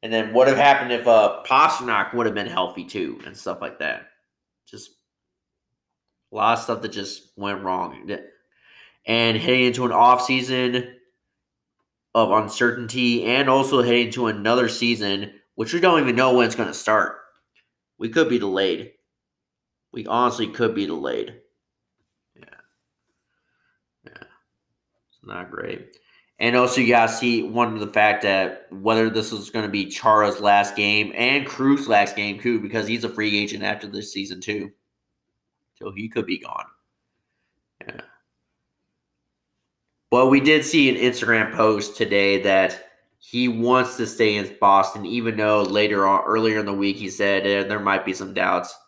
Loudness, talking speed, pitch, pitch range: -20 LUFS, 165 wpm, 110 Hz, 100-125 Hz